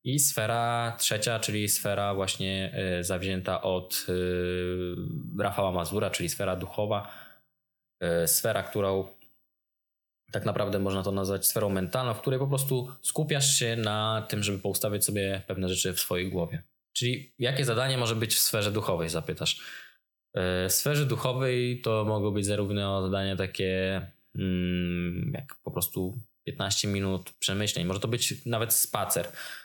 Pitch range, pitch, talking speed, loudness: 95-115 Hz, 105 Hz, 135 wpm, -28 LUFS